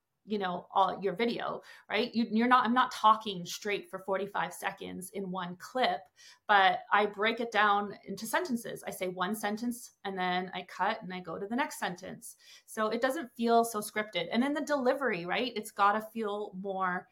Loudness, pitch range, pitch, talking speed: -31 LUFS, 190-235 Hz, 210 Hz, 195 wpm